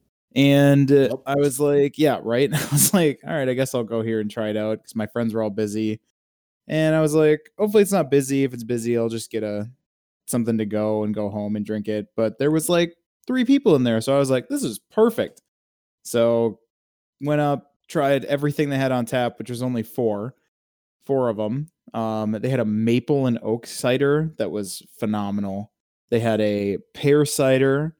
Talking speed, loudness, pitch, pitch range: 210 wpm, -22 LUFS, 120 Hz, 110-145 Hz